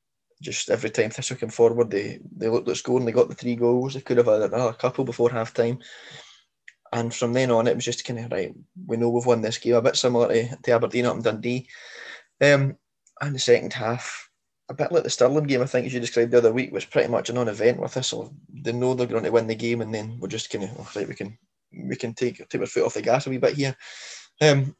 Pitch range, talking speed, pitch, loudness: 115-135 Hz, 255 wpm, 125 Hz, -24 LUFS